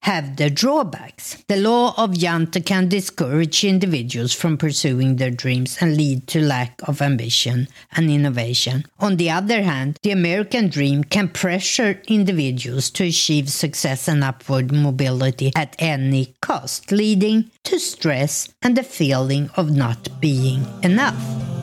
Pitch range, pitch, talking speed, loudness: 135-190 Hz, 155 Hz, 140 wpm, -19 LUFS